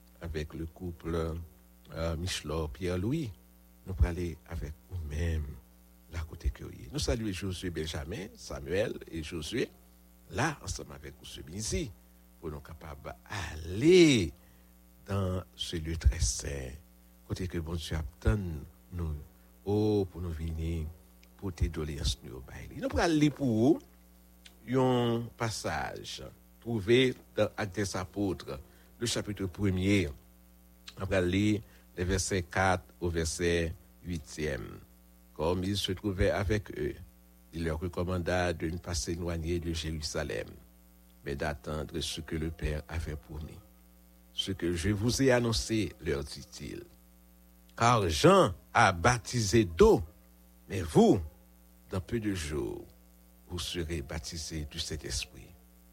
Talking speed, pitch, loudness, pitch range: 130 wpm, 85 Hz, -32 LUFS, 60-95 Hz